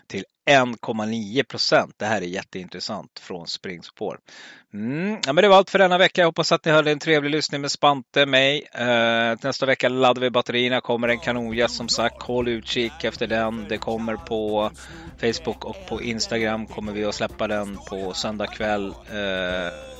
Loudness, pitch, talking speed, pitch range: -22 LUFS, 115 Hz, 175 wpm, 110-135 Hz